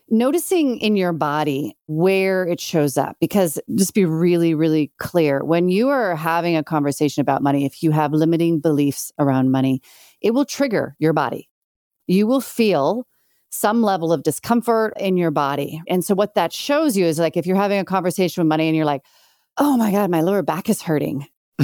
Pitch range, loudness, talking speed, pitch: 150-205 Hz, -19 LUFS, 195 wpm, 170 Hz